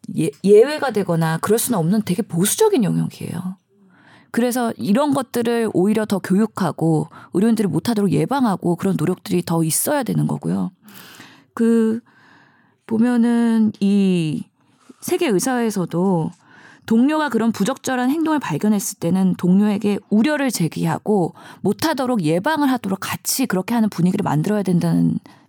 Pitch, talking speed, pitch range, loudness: 205 Hz, 325 characters per minute, 180-235 Hz, -19 LUFS